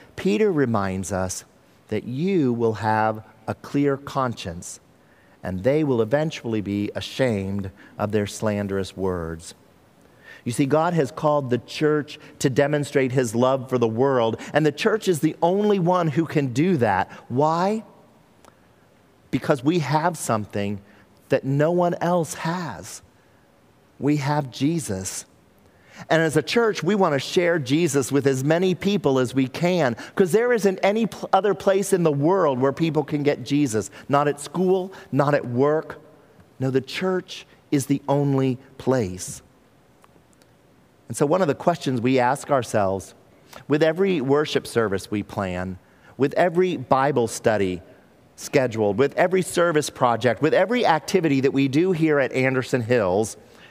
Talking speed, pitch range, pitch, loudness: 150 wpm, 115-165 Hz, 140 Hz, -22 LUFS